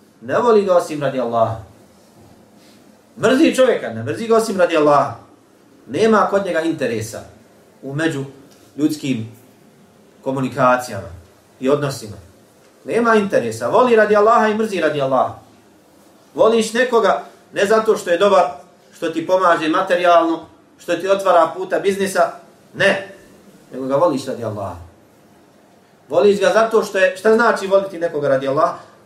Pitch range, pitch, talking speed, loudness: 135-200 Hz, 170 Hz, 135 wpm, -17 LUFS